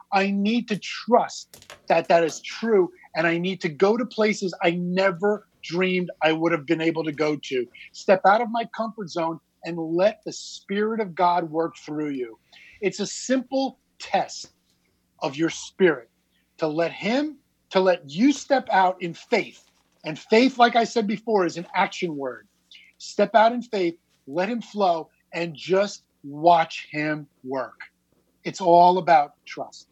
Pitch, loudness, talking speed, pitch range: 185 Hz, -23 LUFS, 170 wpm, 165-215 Hz